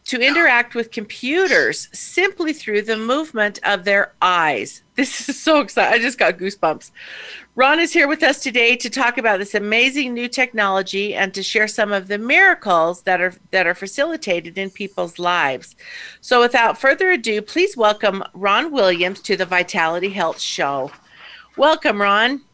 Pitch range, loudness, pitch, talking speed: 195-275 Hz, -17 LUFS, 220 Hz, 165 wpm